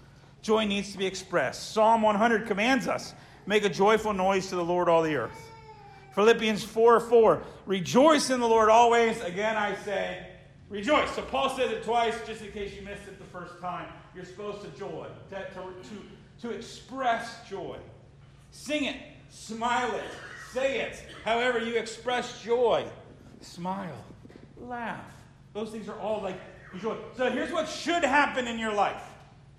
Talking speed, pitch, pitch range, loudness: 165 wpm, 215 Hz, 185-235 Hz, -27 LUFS